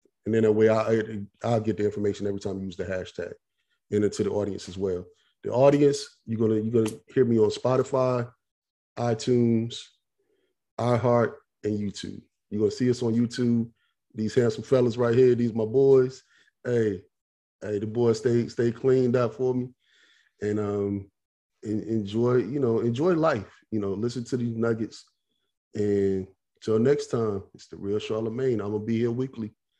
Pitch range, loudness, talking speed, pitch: 105-125 Hz, -26 LUFS, 175 wpm, 115 Hz